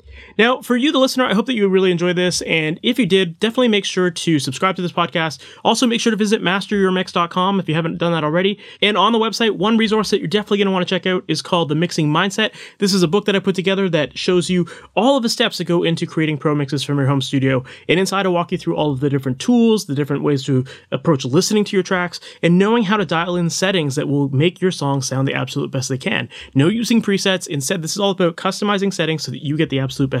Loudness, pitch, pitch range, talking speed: -18 LUFS, 180 Hz, 155-205 Hz, 270 wpm